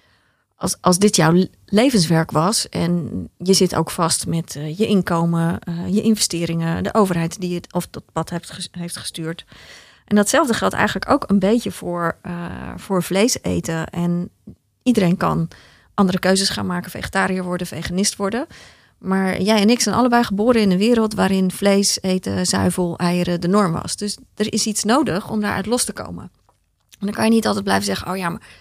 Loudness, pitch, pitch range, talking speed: -19 LUFS, 185 Hz, 170-210 Hz, 190 wpm